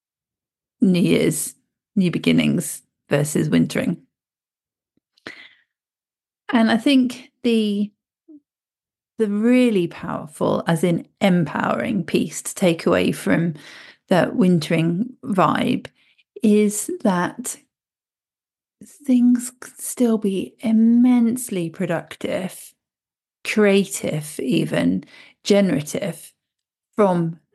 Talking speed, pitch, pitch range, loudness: 75 wpm, 210 Hz, 175-240 Hz, -20 LUFS